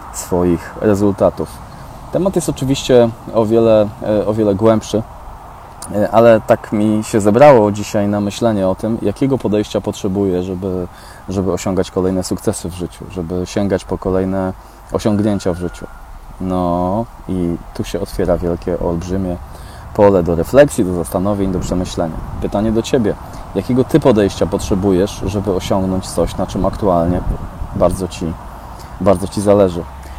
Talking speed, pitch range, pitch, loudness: 135 wpm, 90-105 Hz, 95 Hz, -16 LUFS